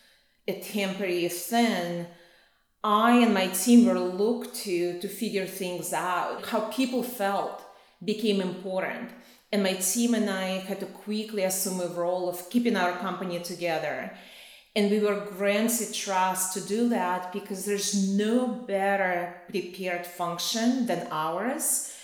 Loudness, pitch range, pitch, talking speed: -27 LUFS, 180-220 Hz, 195 Hz, 140 wpm